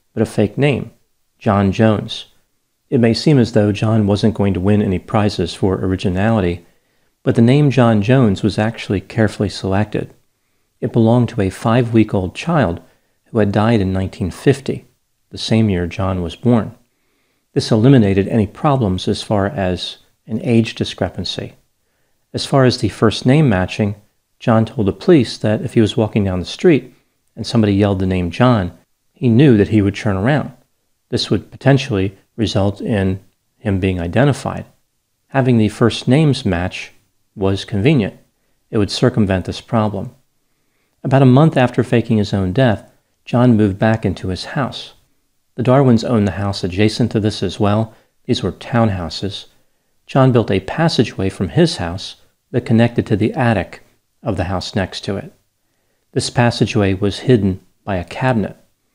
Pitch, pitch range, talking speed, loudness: 110 Hz, 95-120 Hz, 165 wpm, -16 LUFS